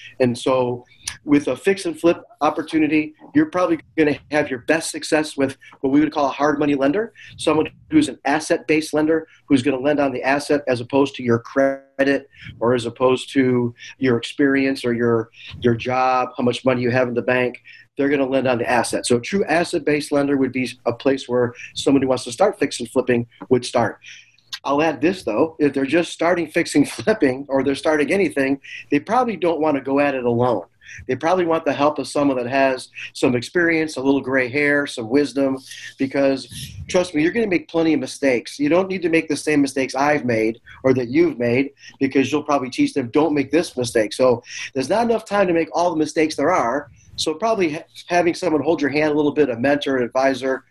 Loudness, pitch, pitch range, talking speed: -20 LUFS, 140 Hz, 130-155 Hz, 220 wpm